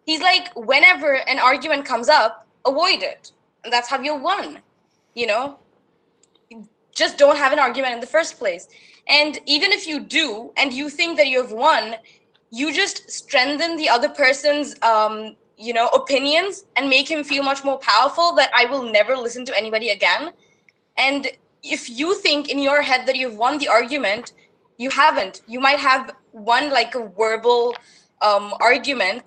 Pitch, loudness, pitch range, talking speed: 270 Hz, -18 LUFS, 240-300 Hz, 170 wpm